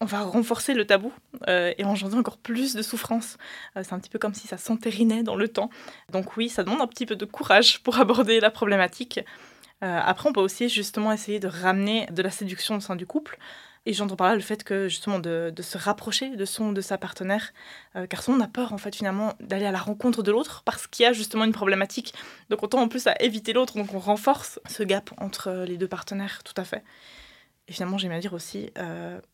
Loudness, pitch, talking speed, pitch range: -25 LUFS, 210 Hz, 245 wpm, 195-235 Hz